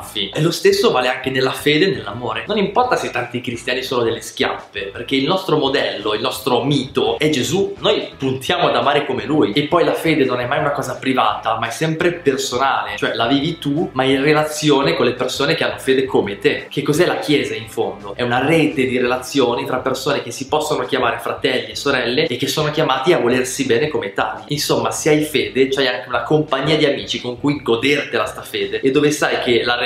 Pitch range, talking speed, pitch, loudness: 125-150 Hz, 220 wpm, 135 Hz, -18 LUFS